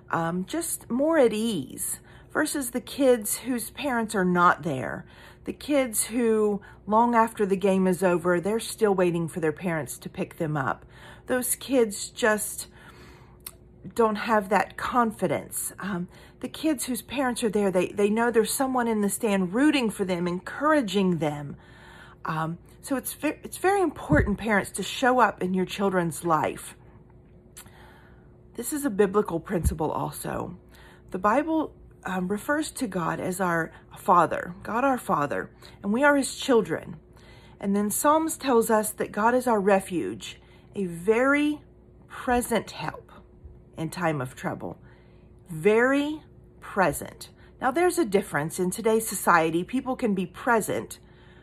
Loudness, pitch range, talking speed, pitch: -26 LUFS, 180-250 Hz, 150 wpm, 210 Hz